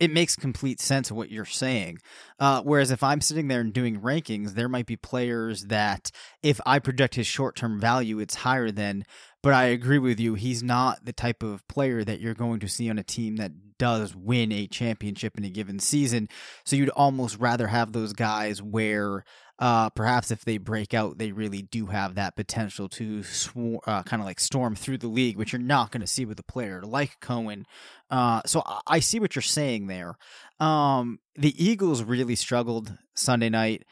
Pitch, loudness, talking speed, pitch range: 115 Hz, -26 LUFS, 205 wpm, 105-130 Hz